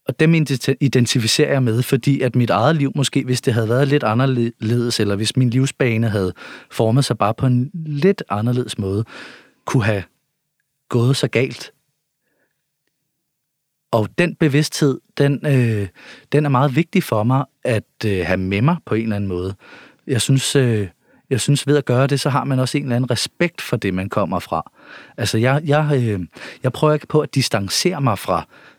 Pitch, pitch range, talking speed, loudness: 130 Hz, 115-145 Hz, 190 wpm, -18 LUFS